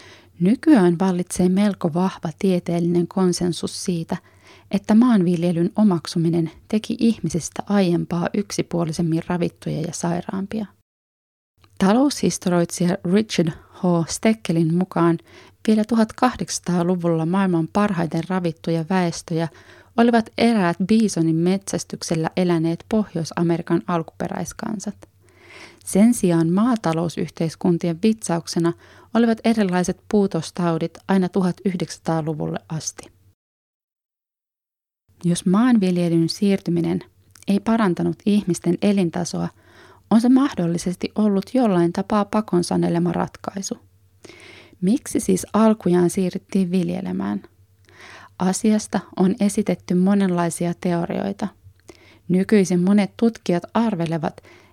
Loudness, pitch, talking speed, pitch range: -21 LUFS, 180 Hz, 80 wpm, 170-205 Hz